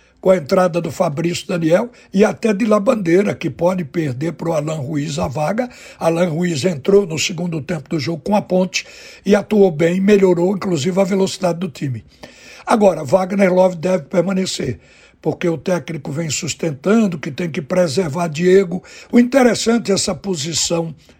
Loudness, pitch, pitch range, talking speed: -17 LUFS, 180 Hz, 165-195 Hz, 170 wpm